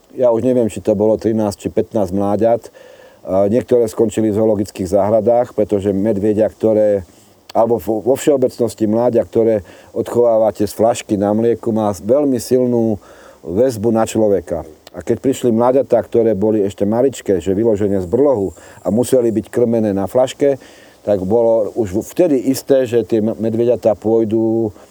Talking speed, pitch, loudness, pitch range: 145 wpm, 110 Hz, -16 LUFS, 105-120 Hz